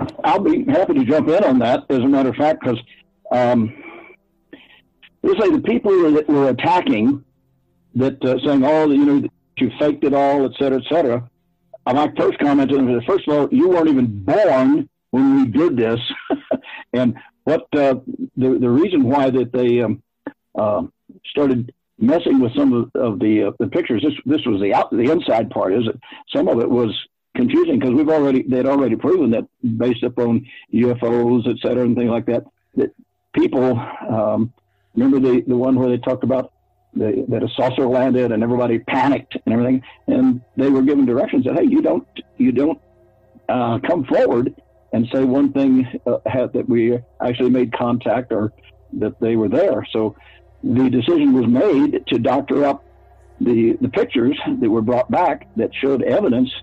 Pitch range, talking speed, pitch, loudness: 120-145 Hz, 185 wpm, 130 Hz, -18 LUFS